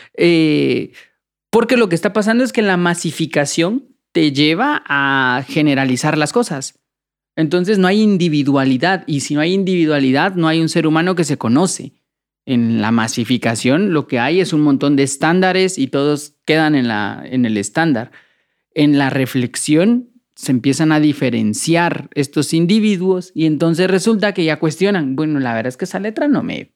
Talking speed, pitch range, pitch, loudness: 170 wpm, 140-185 Hz, 155 Hz, -15 LUFS